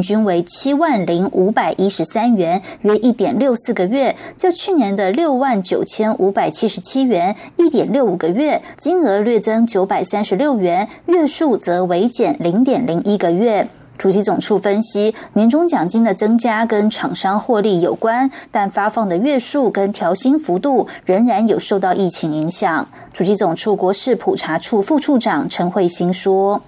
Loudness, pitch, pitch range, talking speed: -16 LUFS, 215 Hz, 190-265 Hz, 260 characters per minute